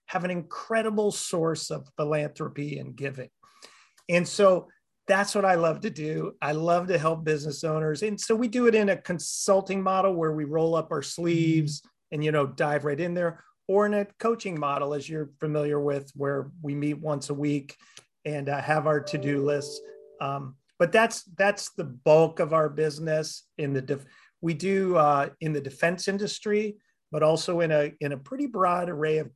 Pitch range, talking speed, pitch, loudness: 145-190 Hz, 190 wpm, 160 Hz, -27 LUFS